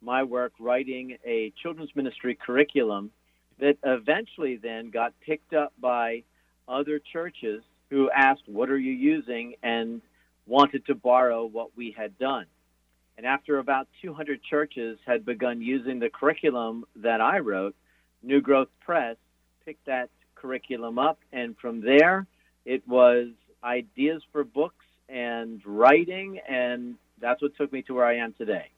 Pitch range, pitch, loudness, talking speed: 115-145 Hz, 125 Hz, -26 LUFS, 145 wpm